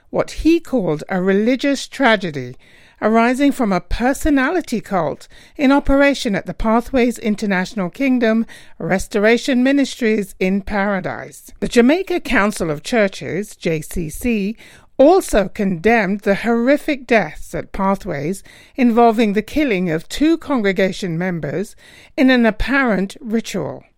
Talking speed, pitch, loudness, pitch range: 115 wpm, 220 Hz, -17 LUFS, 195-260 Hz